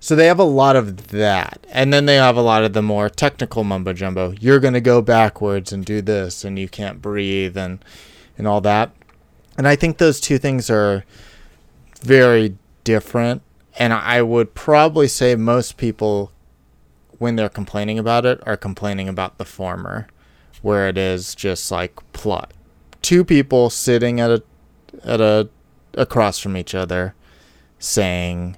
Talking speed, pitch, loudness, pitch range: 165 wpm, 105 Hz, -17 LUFS, 95-120 Hz